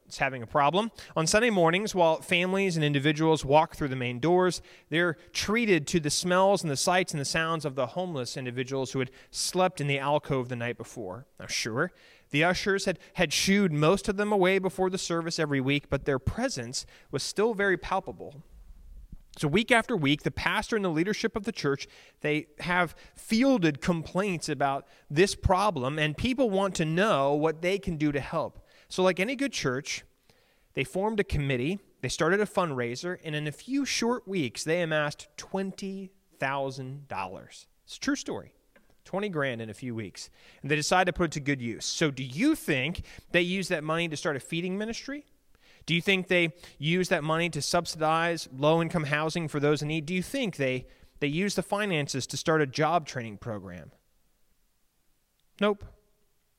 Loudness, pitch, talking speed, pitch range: -28 LUFS, 165 Hz, 190 wpm, 140-190 Hz